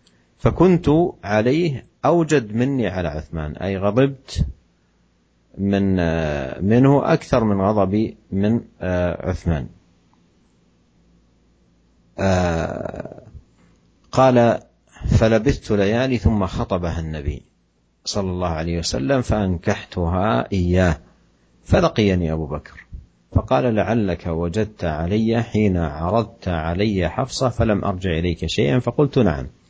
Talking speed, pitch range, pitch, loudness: 90 wpm, 80-115 Hz, 95 Hz, -20 LUFS